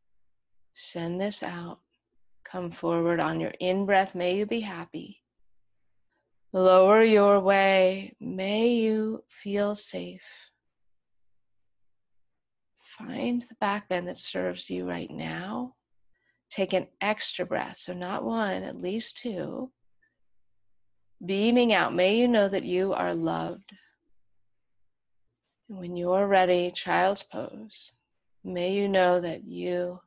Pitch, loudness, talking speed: 185 Hz, -26 LUFS, 120 wpm